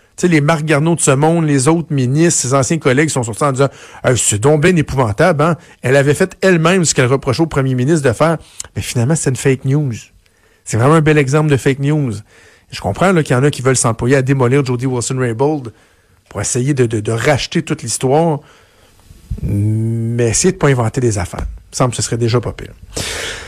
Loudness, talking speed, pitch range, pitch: -14 LUFS, 225 wpm, 115-155 Hz, 135 Hz